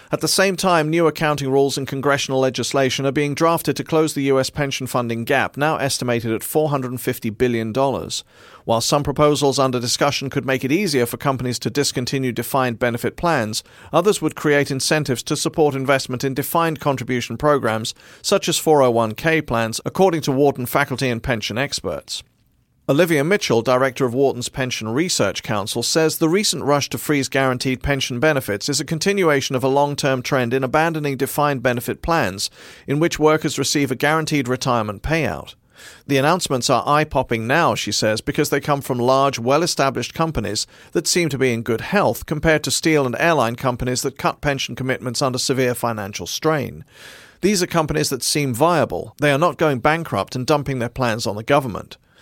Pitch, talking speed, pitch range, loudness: 135 Hz, 180 wpm, 125-150 Hz, -19 LUFS